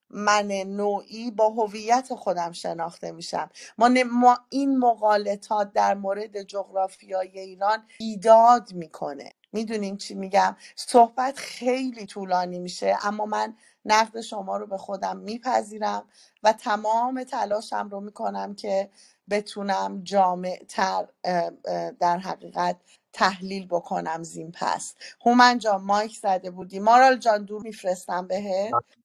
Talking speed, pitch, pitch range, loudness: 115 wpm, 205 Hz, 190-225 Hz, -24 LUFS